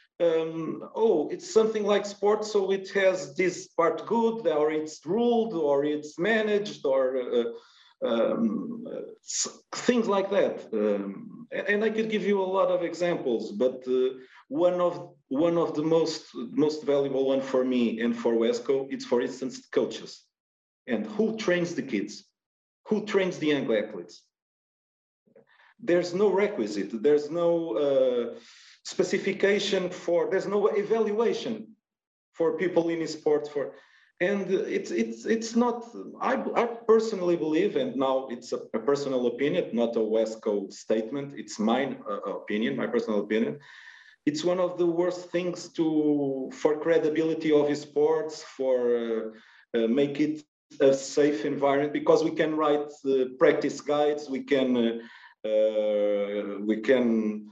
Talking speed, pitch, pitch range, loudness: 150 wpm, 165 Hz, 135-205 Hz, -27 LUFS